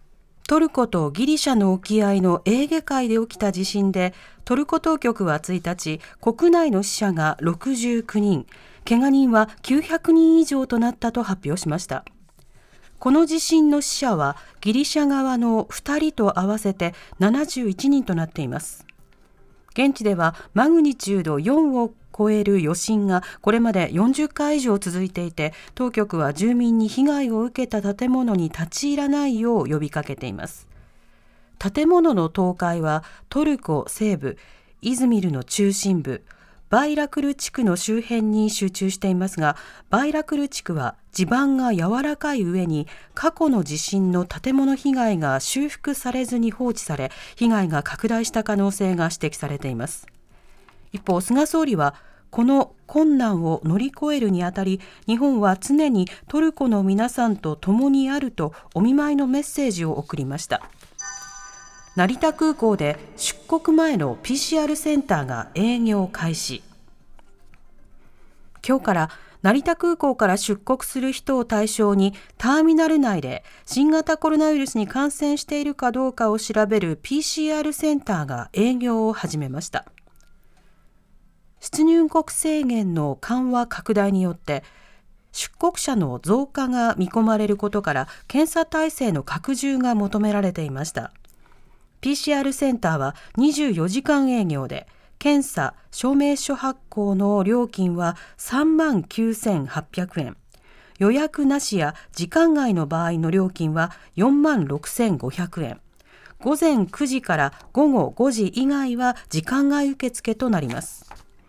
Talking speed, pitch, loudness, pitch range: 265 characters per minute, 220 Hz, -21 LUFS, 180-275 Hz